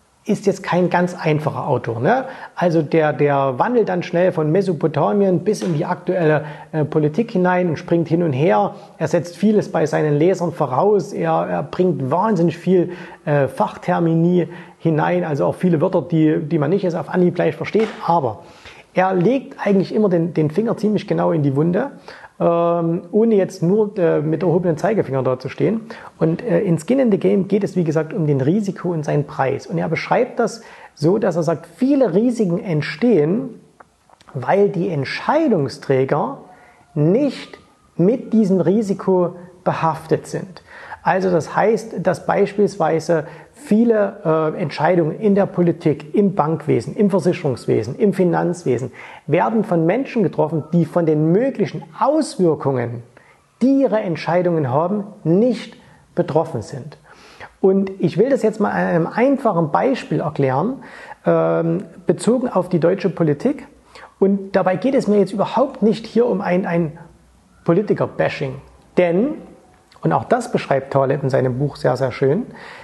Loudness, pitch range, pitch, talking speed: -18 LUFS, 160-200 Hz, 175 Hz, 155 wpm